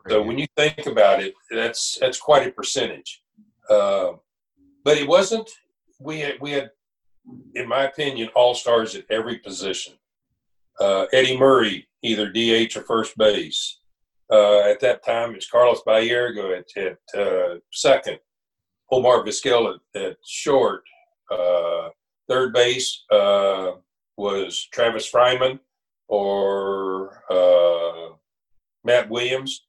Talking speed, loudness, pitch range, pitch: 125 wpm, -20 LUFS, 105-150 Hz, 120 Hz